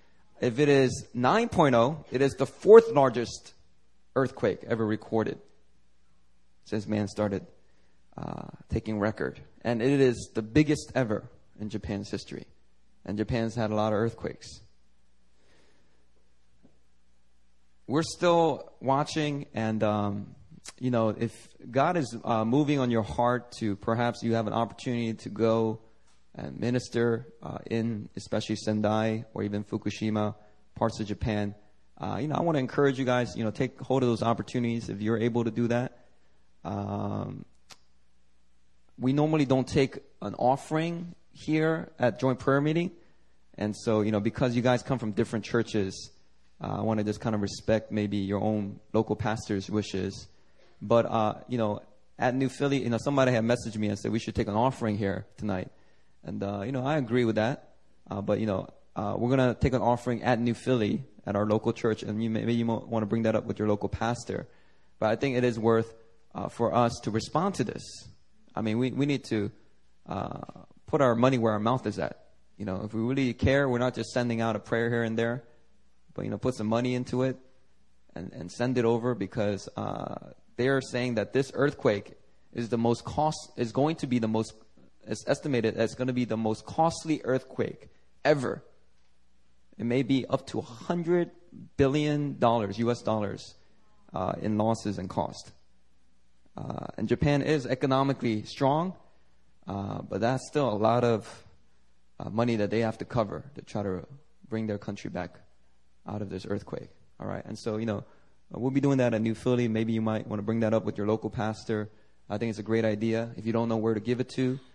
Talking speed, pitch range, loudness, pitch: 190 wpm, 105-125 Hz, -29 LUFS, 115 Hz